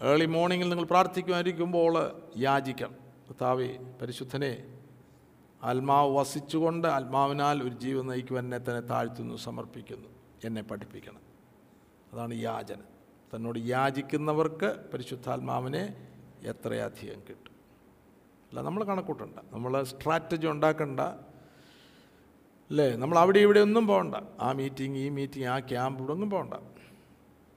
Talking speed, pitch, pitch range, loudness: 100 wpm, 135 Hz, 125-160 Hz, -29 LUFS